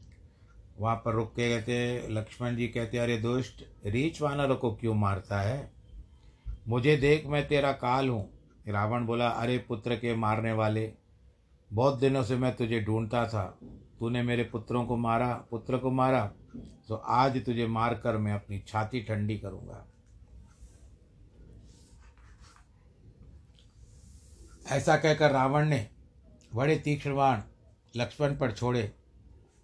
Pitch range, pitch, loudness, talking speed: 105-125 Hz, 115 Hz, -30 LUFS, 125 wpm